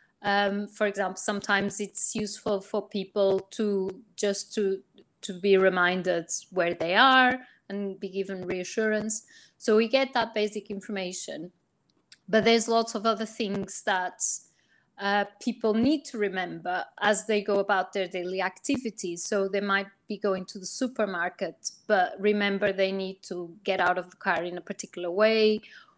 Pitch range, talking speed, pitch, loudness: 190-215 Hz, 155 wpm, 200 Hz, -27 LUFS